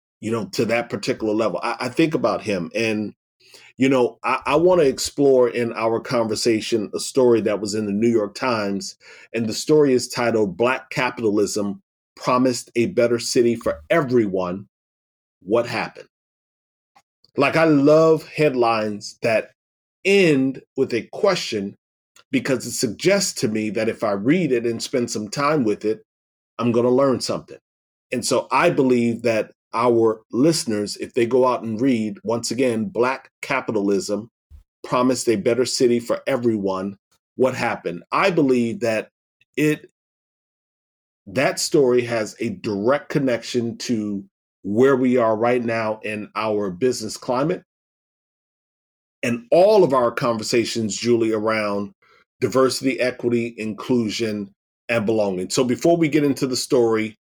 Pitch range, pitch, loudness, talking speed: 105-130 Hz, 115 Hz, -20 LUFS, 145 wpm